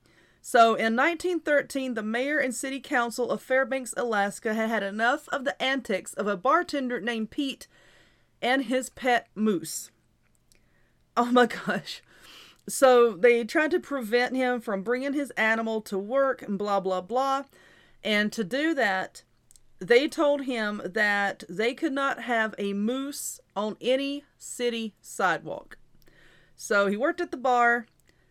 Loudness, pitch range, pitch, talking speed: -26 LUFS, 210-270 Hz, 240 Hz, 145 wpm